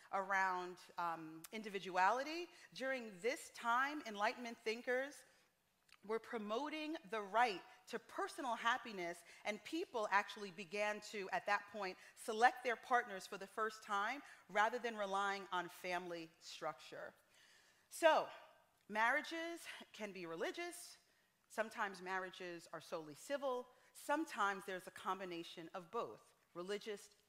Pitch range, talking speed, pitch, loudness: 190-250 Hz, 115 wpm, 215 Hz, -42 LUFS